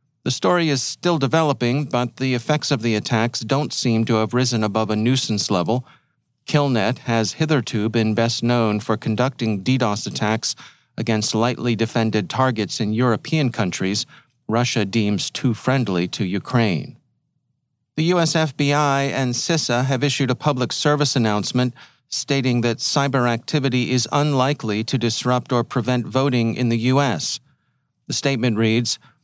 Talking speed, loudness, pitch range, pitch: 145 wpm, -20 LUFS, 115-140 Hz, 125 Hz